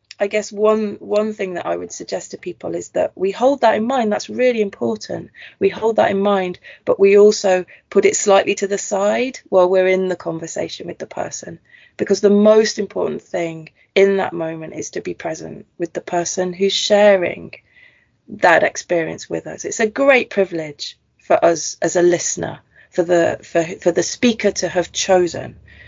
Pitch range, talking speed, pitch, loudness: 175-210 Hz, 190 wpm, 195 Hz, -17 LUFS